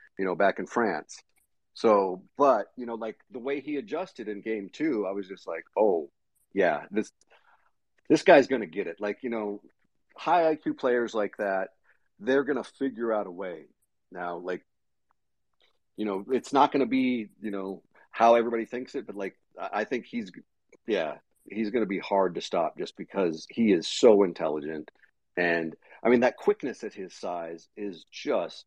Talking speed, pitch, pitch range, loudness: 185 wpm, 110 Hz, 95-125 Hz, -28 LUFS